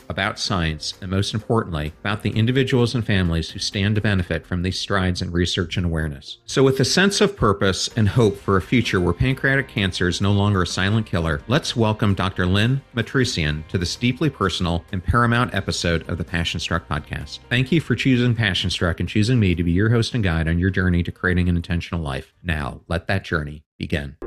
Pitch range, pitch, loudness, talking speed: 85-115 Hz, 95 Hz, -21 LUFS, 215 wpm